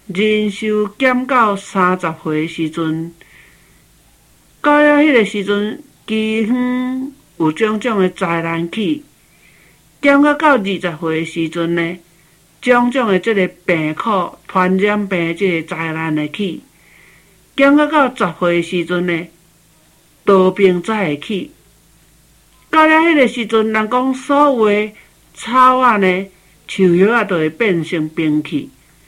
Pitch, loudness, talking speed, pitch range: 190 Hz, -15 LUFS, 175 characters per minute, 165-235 Hz